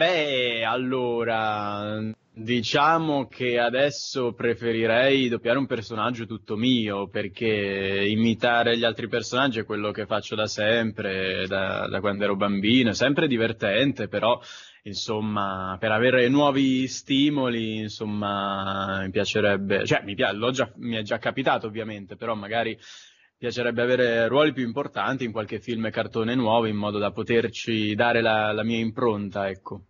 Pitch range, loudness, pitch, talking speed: 105-120 Hz, -24 LUFS, 115 Hz, 145 wpm